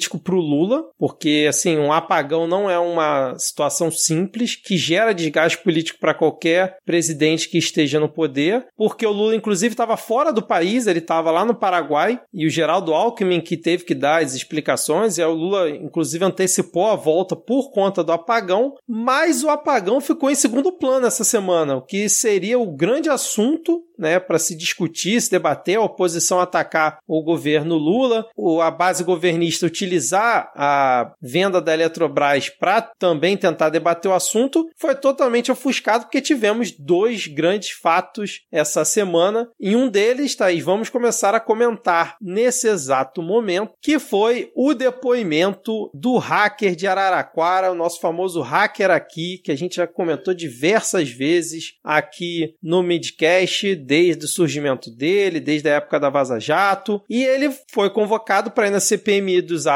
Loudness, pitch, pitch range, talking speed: -19 LUFS, 185 Hz, 165-225 Hz, 165 wpm